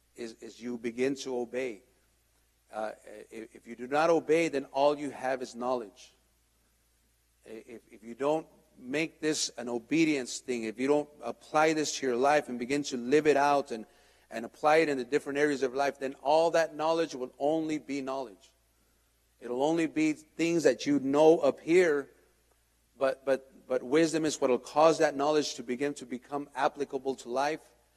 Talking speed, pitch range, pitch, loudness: 185 wpm, 125-155 Hz, 140 Hz, -29 LUFS